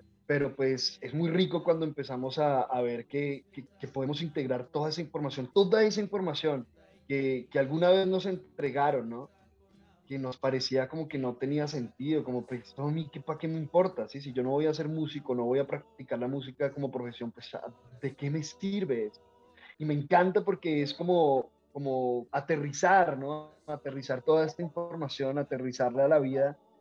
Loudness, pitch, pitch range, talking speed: -31 LUFS, 145 Hz, 130-160 Hz, 185 wpm